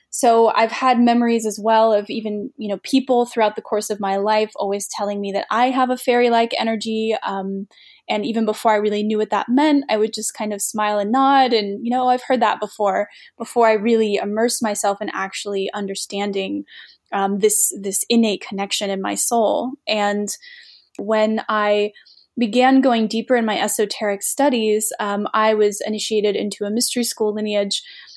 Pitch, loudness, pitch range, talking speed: 215 Hz, -19 LUFS, 205-235 Hz, 185 wpm